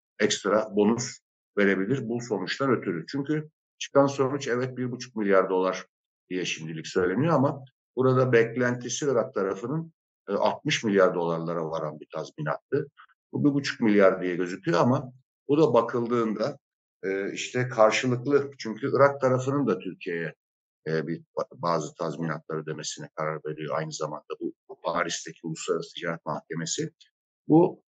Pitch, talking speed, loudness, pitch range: 120 Hz, 130 wpm, -27 LUFS, 90-140 Hz